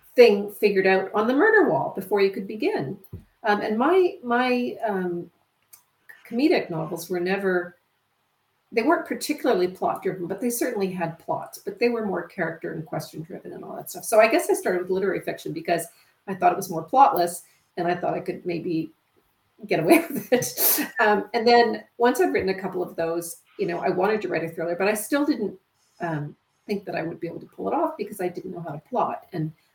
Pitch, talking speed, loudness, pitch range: 195 Hz, 220 wpm, -24 LUFS, 175-240 Hz